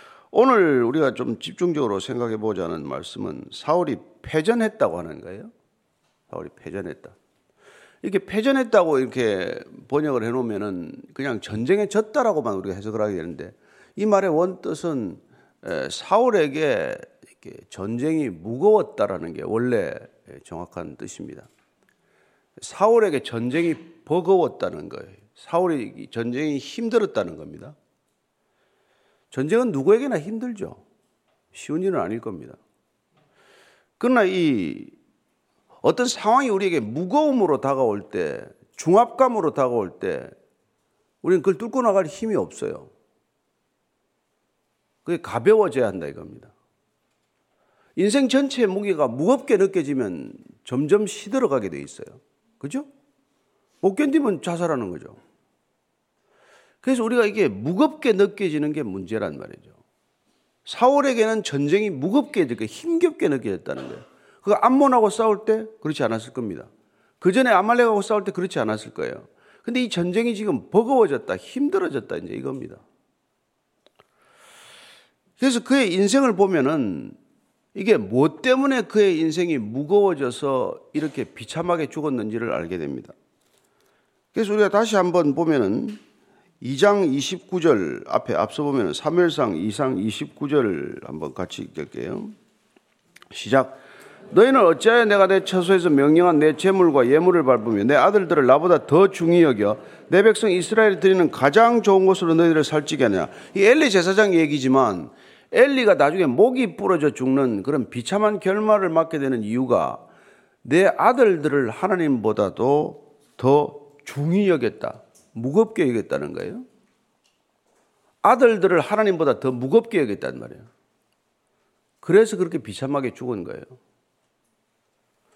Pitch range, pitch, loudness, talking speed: 150-240 Hz, 200 Hz, -21 LUFS, 290 characters per minute